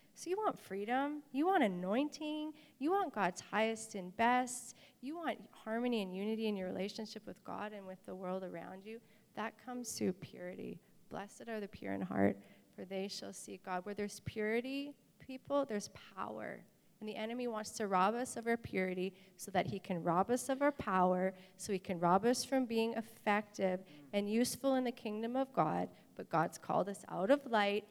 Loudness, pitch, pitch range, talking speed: -38 LUFS, 215 Hz, 190-245 Hz, 195 wpm